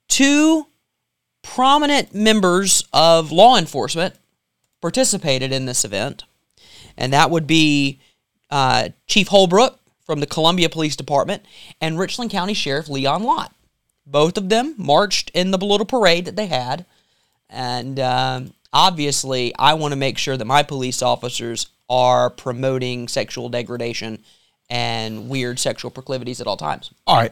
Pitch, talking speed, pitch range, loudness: 140 Hz, 140 wpm, 125-180 Hz, -18 LUFS